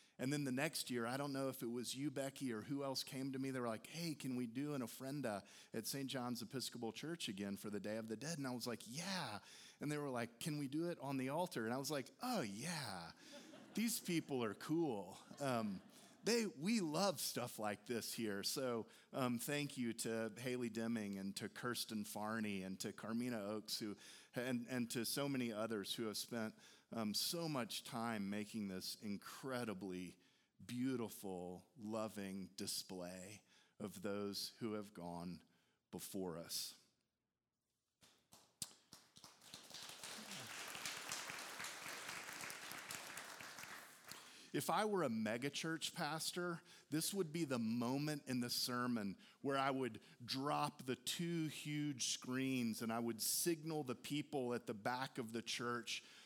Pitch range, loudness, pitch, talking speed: 110-145 Hz, -44 LUFS, 125 Hz, 160 wpm